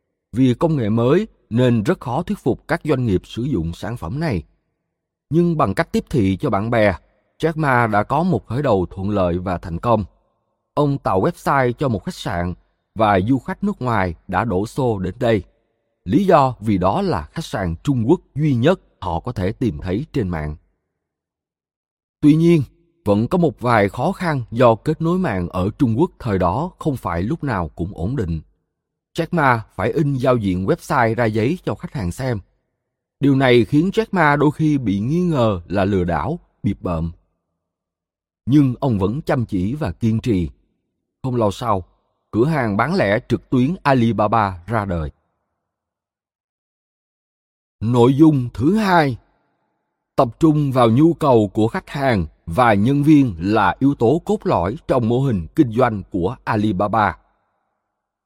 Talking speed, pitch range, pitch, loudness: 175 wpm, 95-150 Hz, 120 Hz, -19 LUFS